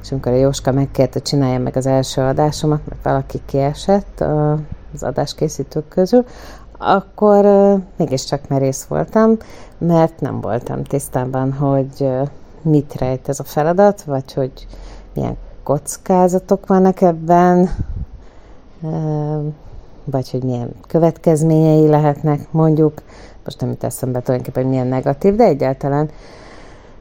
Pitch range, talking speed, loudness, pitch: 130-165 Hz, 120 wpm, -16 LUFS, 145 Hz